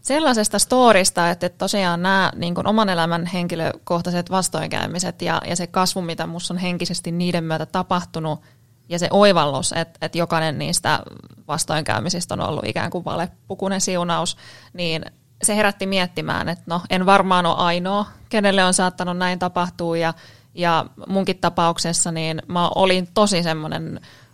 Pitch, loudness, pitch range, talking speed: 175 Hz, -20 LUFS, 165-190 Hz, 150 wpm